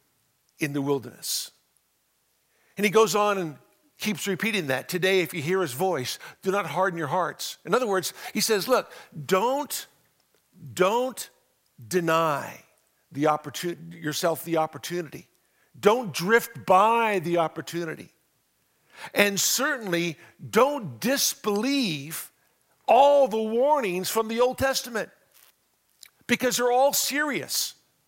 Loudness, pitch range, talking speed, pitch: -25 LUFS, 165-225 Hz, 115 wpm, 185 Hz